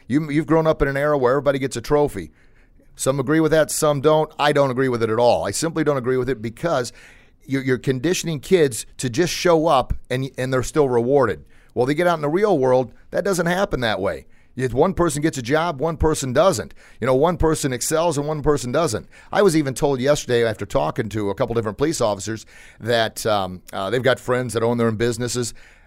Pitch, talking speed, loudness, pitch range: 135 Hz, 225 wpm, -20 LUFS, 120-155 Hz